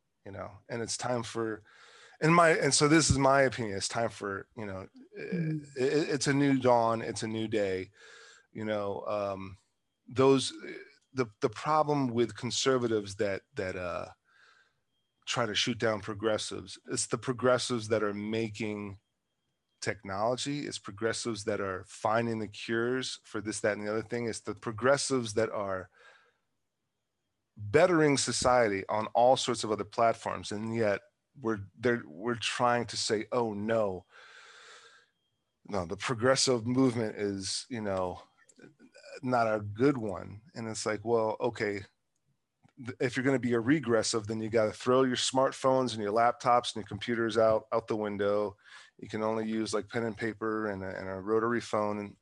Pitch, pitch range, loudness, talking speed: 115 Hz, 105-130 Hz, -30 LUFS, 165 wpm